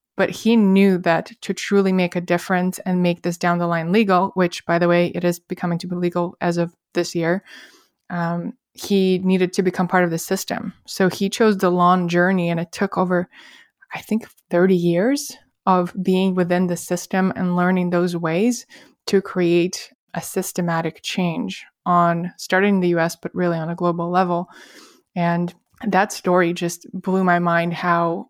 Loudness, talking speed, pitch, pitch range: -20 LUFS, 180 wpm, 180 Hz, 175-190 Hz